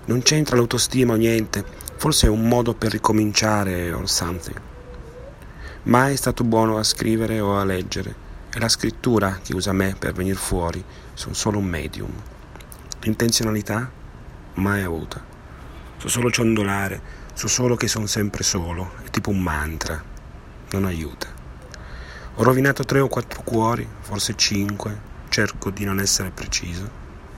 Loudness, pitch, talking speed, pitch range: -21 LUFS, 100 Hz, 145 wpm, 90-115 Hz